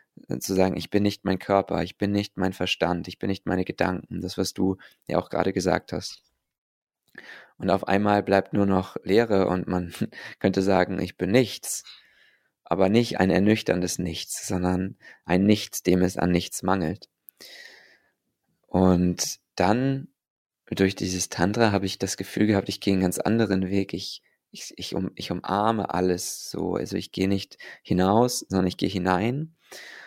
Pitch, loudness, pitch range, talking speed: 95 Hz, -25 LUFS, 90-100 Hz, 170 wpm